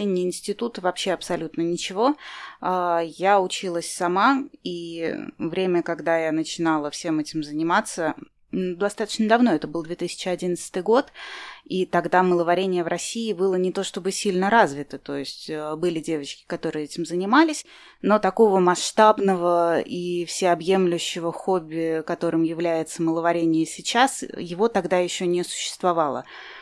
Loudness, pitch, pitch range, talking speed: -23 LUFS, 175 Hz, 165-195 Hz, 125 wpm